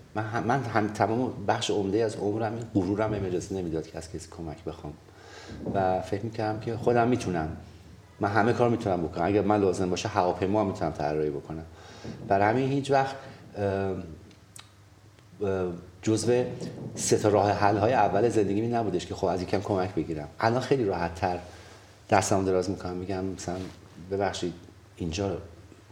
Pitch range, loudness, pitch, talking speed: 90-110 Hz, -28 LUFS, 100 Hz, 155 wpm